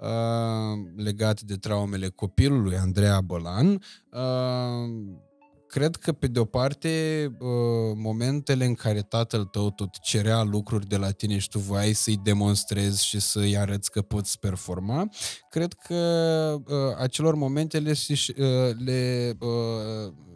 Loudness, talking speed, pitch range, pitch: -26 LUFS, 115 wpm, 105-135 Hz, 115 Hz